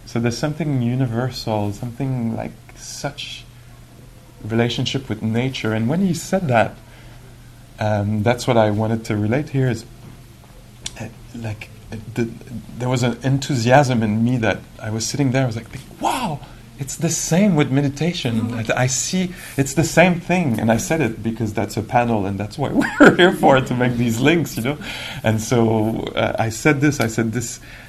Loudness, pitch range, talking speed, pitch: -19 LUFS, 115-135 Hz, 185 wpm, 120 Hz